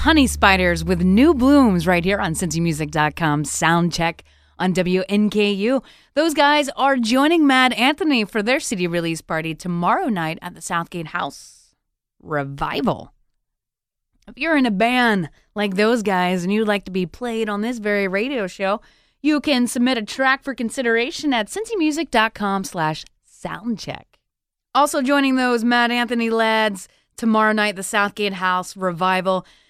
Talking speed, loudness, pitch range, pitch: 150 wpm, -19 LUFS, 180-255 Hz, 210 Hz